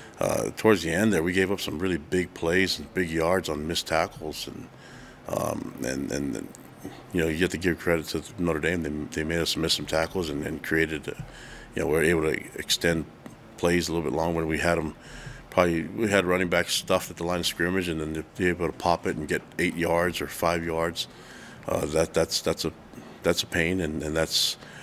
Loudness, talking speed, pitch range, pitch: -26 LUFS, 230 wpm, 80-90 Hz, 85 Hz